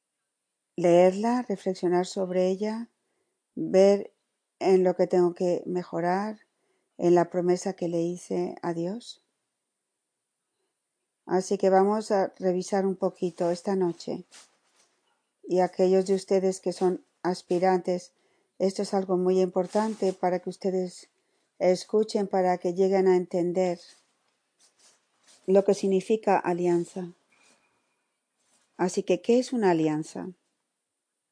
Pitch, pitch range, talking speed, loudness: 185 Hz, 180-195 Hz, 115 wpm, -26 LUFS